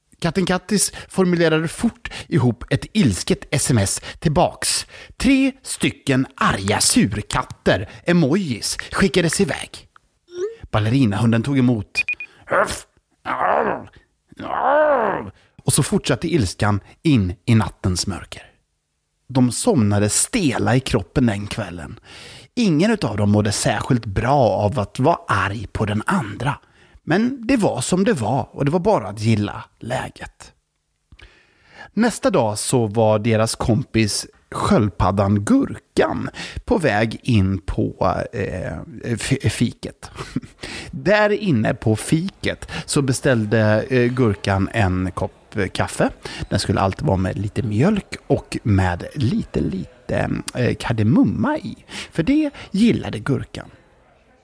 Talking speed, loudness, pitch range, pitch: 110 wpm, -20 LUFS, 105-170 Hz, 115 Hz